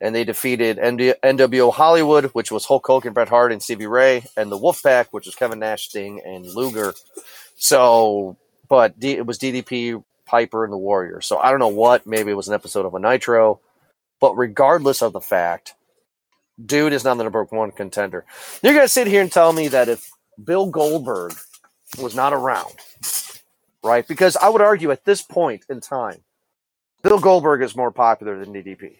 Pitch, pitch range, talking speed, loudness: 120 Hz, 110-140 Hz, 190 wpm, -18 LUFS